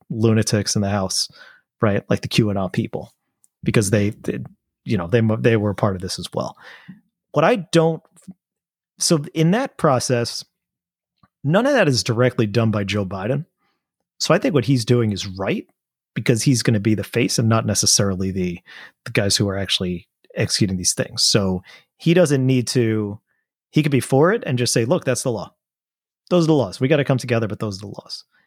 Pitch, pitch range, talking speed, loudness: 120 Hz, 105-140 Hz, 205 wpm, -19 LUFS